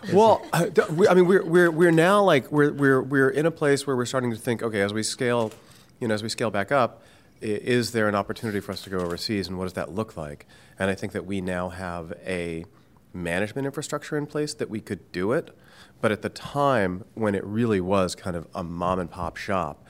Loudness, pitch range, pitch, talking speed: -24 LUFS, 95-135 Hz, 110 Hz, 225 wpm